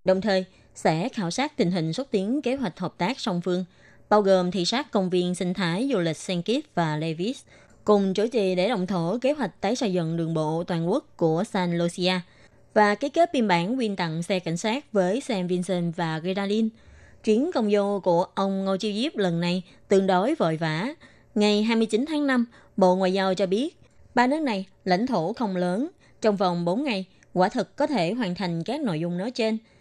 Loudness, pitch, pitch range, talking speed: -25 LUFS, 195 Hz, 180-230 Hz, 215 wpm